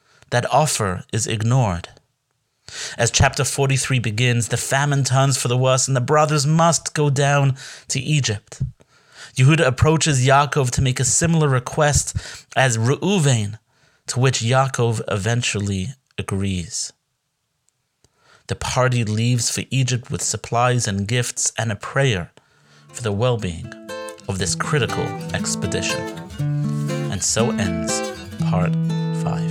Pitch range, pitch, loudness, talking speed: 110-140 Hz, 125 Hz, -20 LUFS, 125 wpm